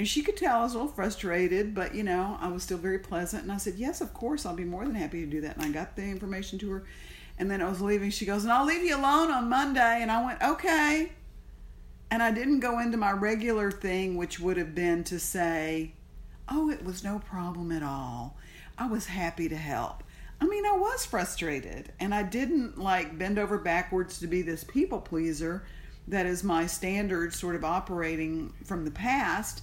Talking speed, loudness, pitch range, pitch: 220 wpm, -30 LUFS, 170-230 Hz, 190 Hz